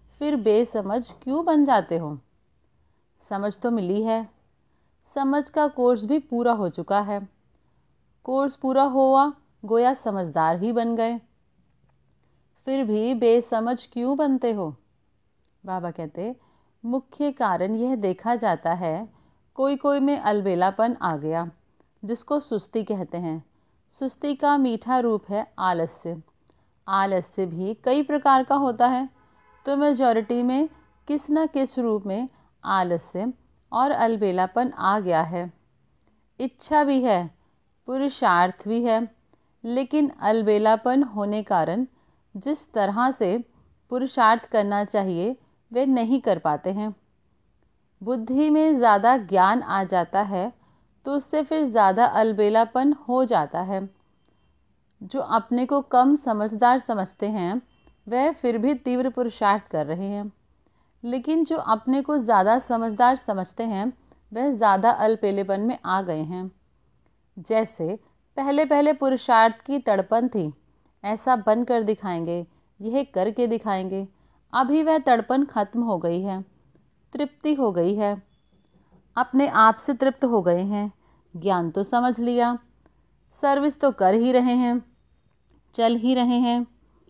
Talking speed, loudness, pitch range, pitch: 130 wpm, -23 LUFS, 195-260 Hz, 230 Hz